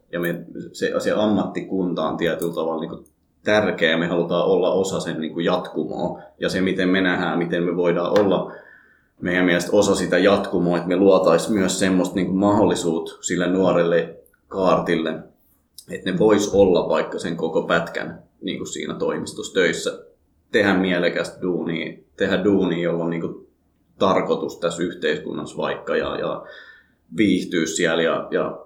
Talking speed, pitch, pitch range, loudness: 145 wpm, 90 Hz, 85-100 Hz, -21 LUFS